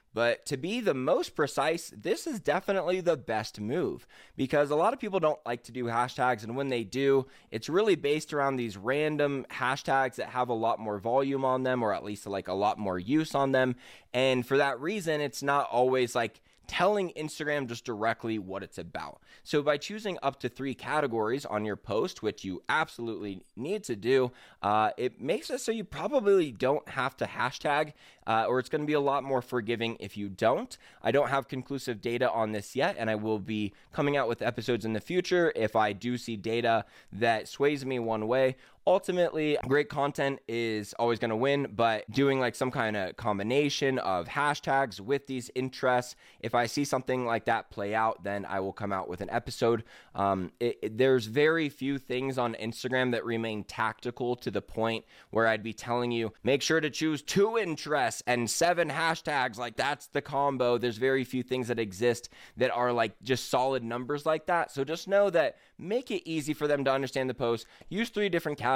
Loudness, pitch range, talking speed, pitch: -30 LUFS, 115-145 Hz, 205 wpm, 130 Hz